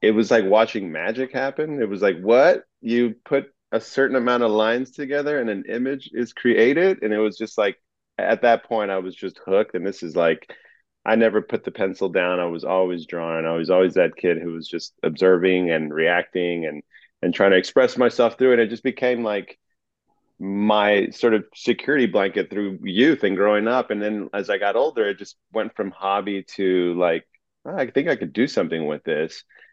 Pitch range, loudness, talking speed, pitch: 95-120 Hz, -21 LUFS, 210 wpm, 105 Hz